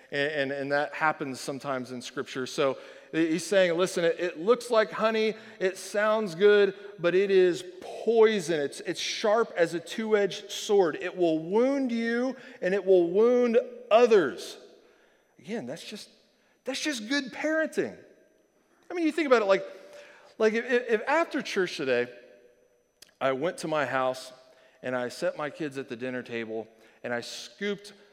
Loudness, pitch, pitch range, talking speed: -27 LUFS, 195 Hz, 150-230 Hz, 165 wpm